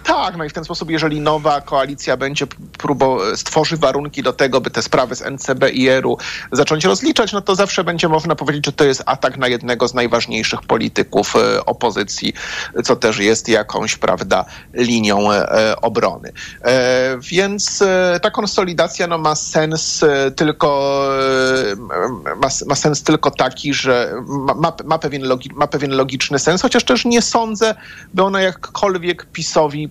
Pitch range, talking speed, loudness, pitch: 130-175 Hz, 150 wpm, -16 LUFS, 150 Hz